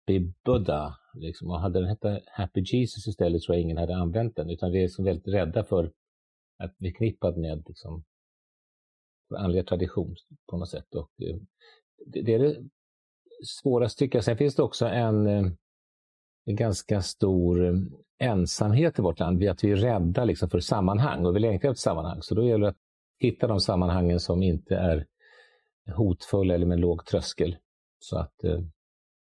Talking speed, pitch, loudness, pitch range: 170 wpm, 95 Hz, -27 LUFS, 85-110 Hz